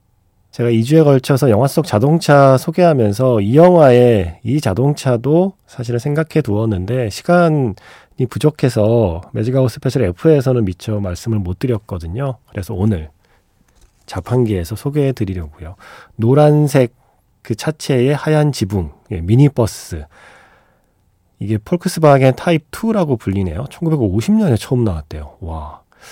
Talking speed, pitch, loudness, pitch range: 285 characters per minute, 125 Hz, -15 LUFS, 100-145 Hz